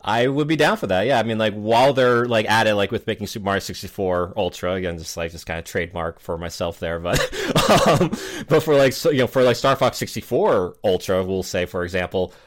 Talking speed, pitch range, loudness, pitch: 240 wpm, 95-125 Hz, -20 LUFS, 110 Hz